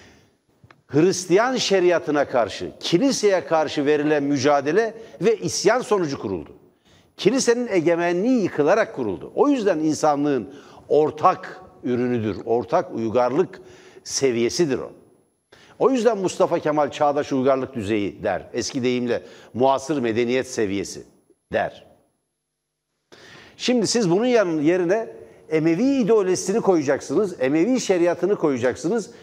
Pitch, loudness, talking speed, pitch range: 155 Hz, -21 LUFS, 100 wpm, 130-190 Hz